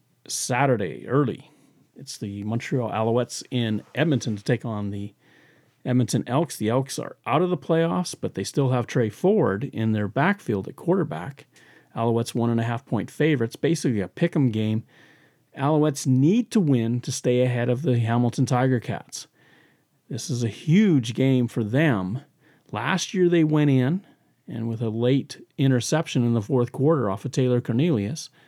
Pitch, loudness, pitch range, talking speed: 130 Hz, -24 LUFS, 115-150 Hz, 170 wpm